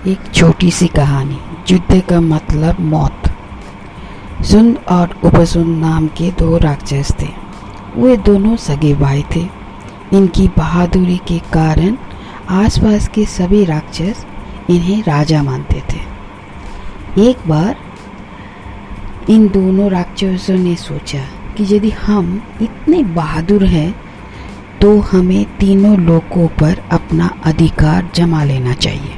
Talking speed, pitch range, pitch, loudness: 115 wpm, 150-195 Hz, 170 Hz, -13 LUFS